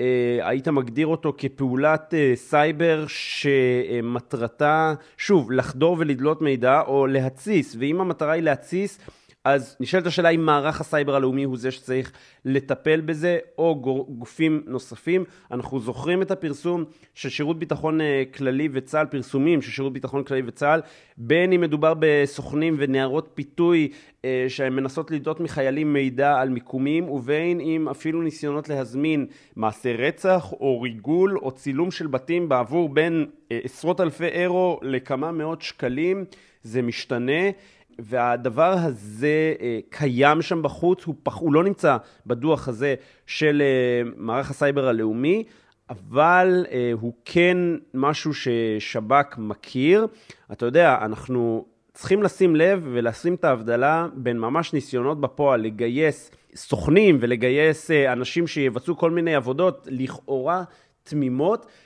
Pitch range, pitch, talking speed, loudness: 130-165 Hz, 145 Hz, 125 wpm, -22 LUFS